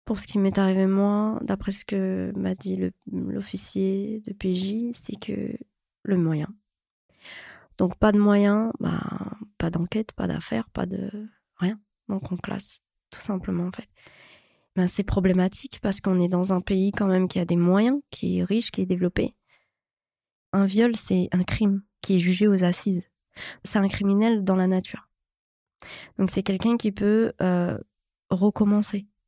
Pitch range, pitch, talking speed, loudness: 185-210 Hz, 195 Hz, 170 wpm, -25 LUFS